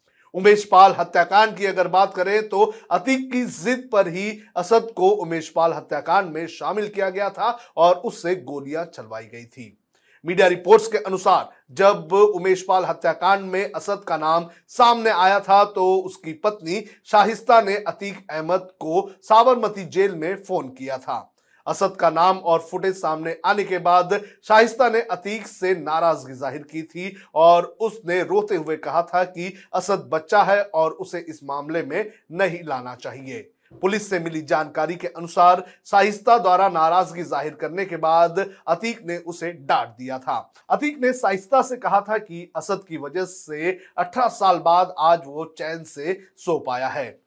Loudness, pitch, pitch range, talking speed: -20 LUFS, 185 Hz, 165-205 Hz, 170 wpm